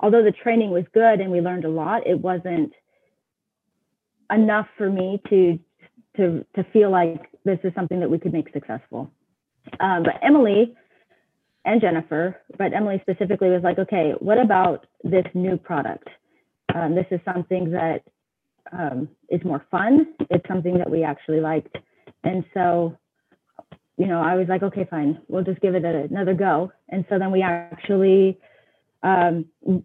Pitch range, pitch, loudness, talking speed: 170-195 Hz, 185 Hz, -21 LUFS, 165 wpm